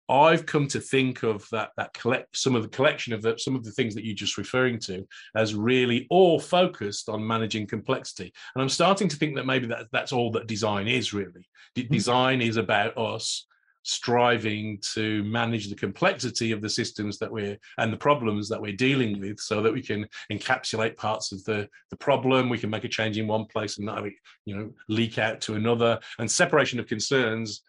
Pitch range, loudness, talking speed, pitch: 105-130 Hz, -26 LUFS, 210 wpm, 115 Hz